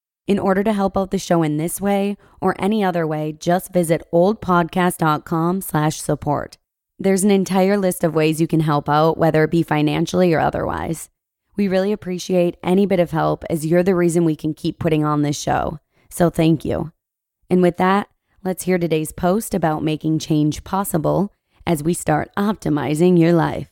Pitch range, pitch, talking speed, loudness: 155-185 Hz, 175 Hz, 180 wpm, -19 LUFS